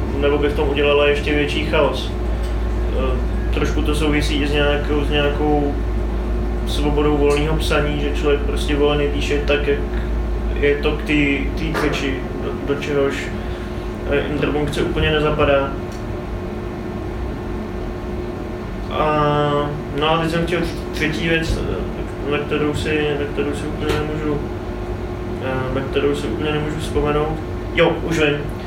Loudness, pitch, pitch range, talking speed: -20 LUFS, 145 Hz, 95-150 Hz, 130 wpm